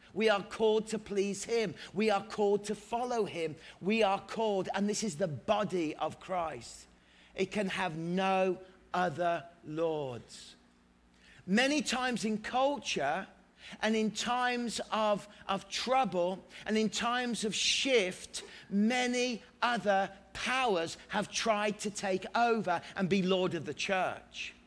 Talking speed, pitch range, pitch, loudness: 140 wpm, 175-220 Hz, 200 Hz, -32 LUFS